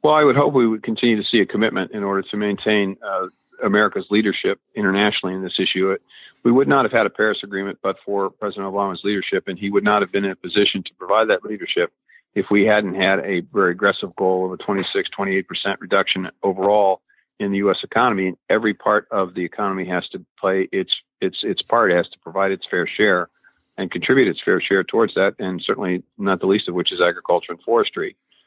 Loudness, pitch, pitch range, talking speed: -20 LUFS, 100 Hz, 95-105 Hz, 220 wpm